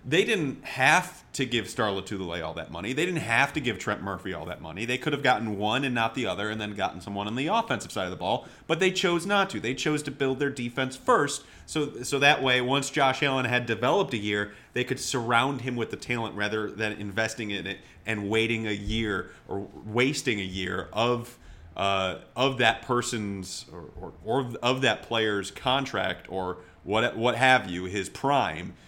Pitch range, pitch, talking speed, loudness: 100-130 Hz, 115 Hz, 210 wpm, -27 LUFS